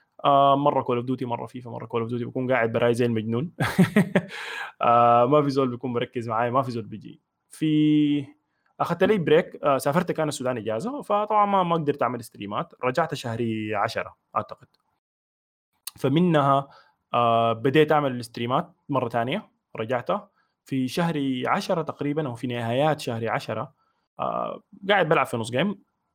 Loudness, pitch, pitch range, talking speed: -24 LUFS, 135 Hz, 120-165 Hz, 150 wpm